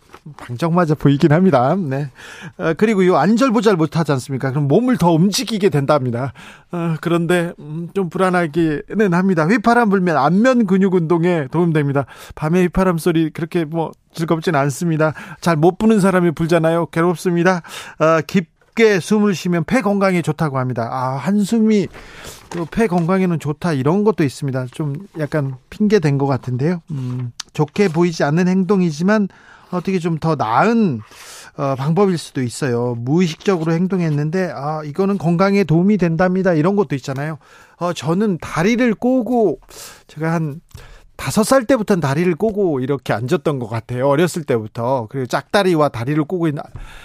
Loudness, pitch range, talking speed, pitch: -17 LUFS, 150-195 Hz, 340 characters per minute, 170 Hz